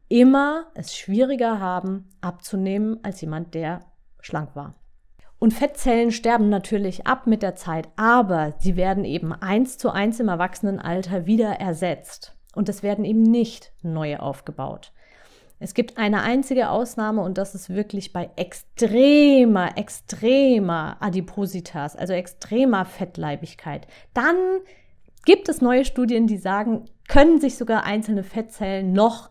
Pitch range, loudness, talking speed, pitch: 180-235 Hz, -21 LUFS, 135 wpm, 205 Hz